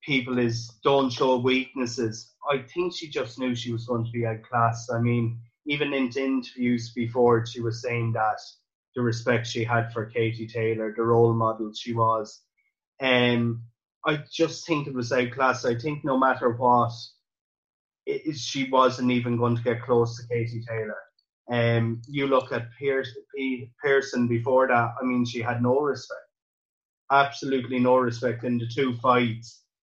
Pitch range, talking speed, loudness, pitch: 115-130 Hz, 170 wpm, -25 LUFS, 120 Hz